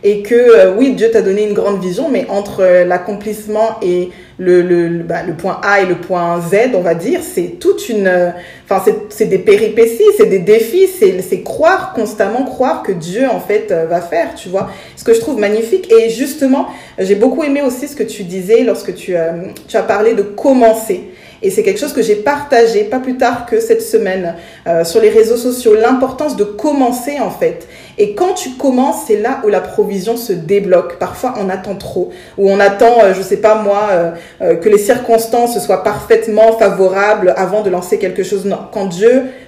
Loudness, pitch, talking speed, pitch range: -12 LUFS, 220 Hz, 215 wpm, 195-285 Hz